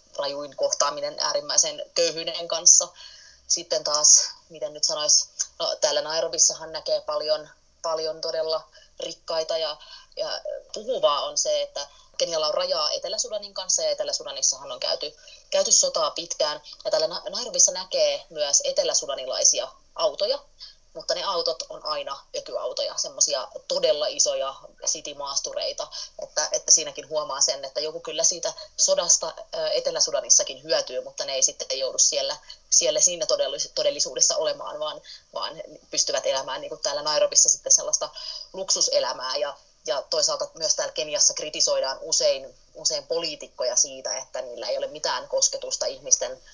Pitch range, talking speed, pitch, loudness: 280-315 Hz, 135 wpm, 300 Hz, -23 LUFS